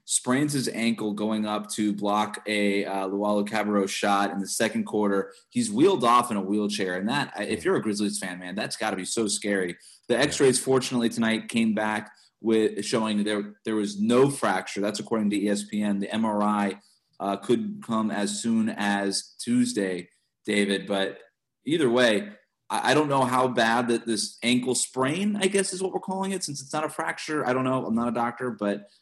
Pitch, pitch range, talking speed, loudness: 105 Hz, 100-125 Hz, 190 wpm, -26 LUFS